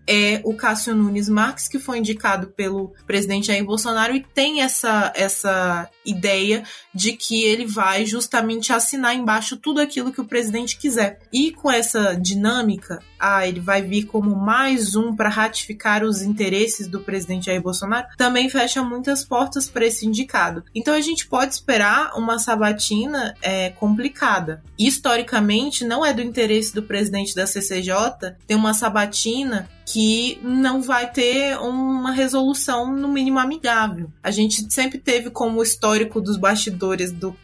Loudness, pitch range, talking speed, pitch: -19 LUFS, 205-250 Hz, 155 wpm, 220 Hz